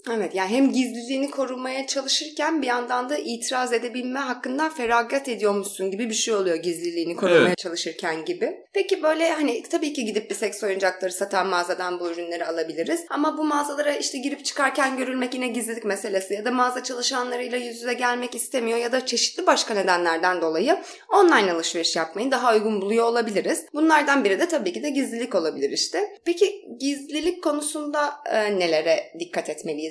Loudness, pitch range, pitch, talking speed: -23 LUFS, 200-295 Hz, 250 Hz, 165 wpm